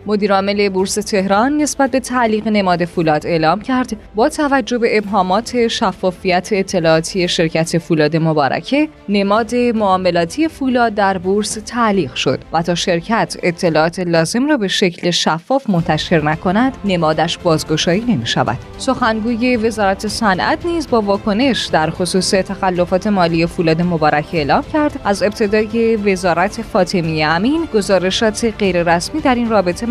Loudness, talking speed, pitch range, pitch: -15 LUFS, 130 wpm, 175-230 Hz, 195 Hz